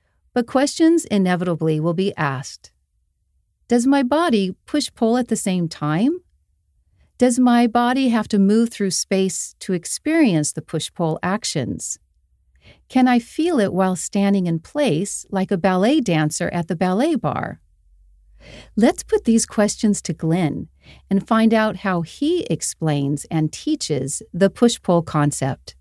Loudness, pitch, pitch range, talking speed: -20 LUFS, 195 Hz, 160-240 Hz, 140 wpm